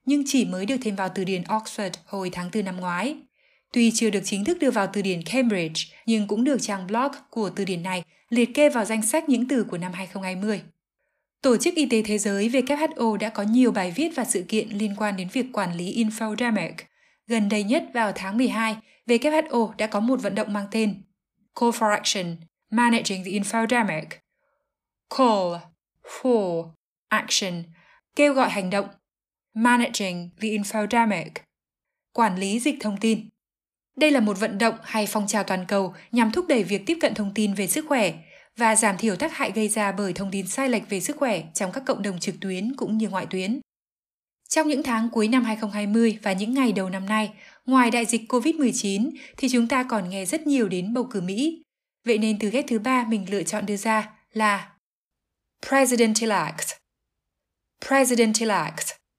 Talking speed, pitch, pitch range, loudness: 190 wpm, 220 Hz, 200-245 Hz, -24 LUFS